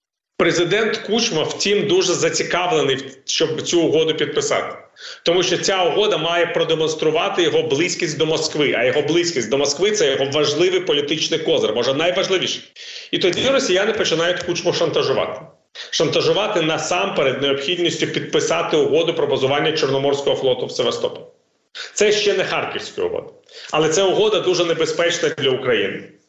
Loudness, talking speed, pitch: -18 LUFS, 135 wpm, 370 Hz